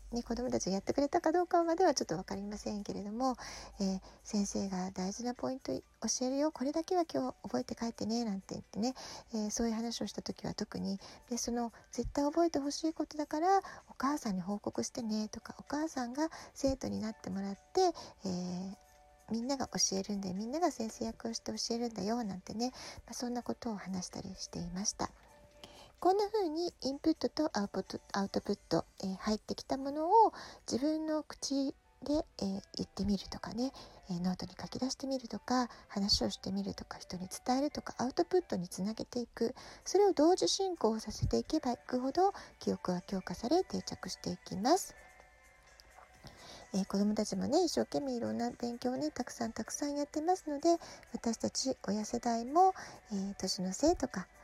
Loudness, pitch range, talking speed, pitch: -36 LUFS, 200-290 Hz, 370 characters per minute, 235 Hz